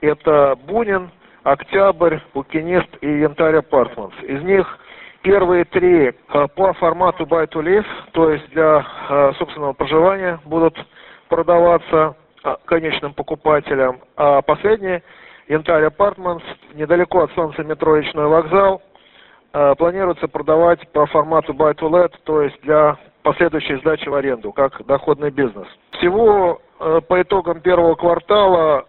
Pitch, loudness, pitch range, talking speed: 160 Hz, -16 LUFS, 150-180 Hz, 110 wpm